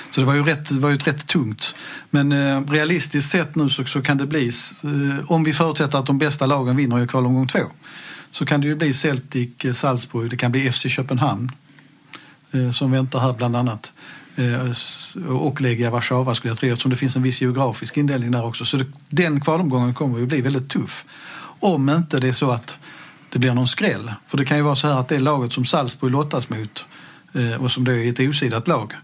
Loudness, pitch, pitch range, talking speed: -20 LUFS, 135 Hz, 125-150 Hz, 220 wpm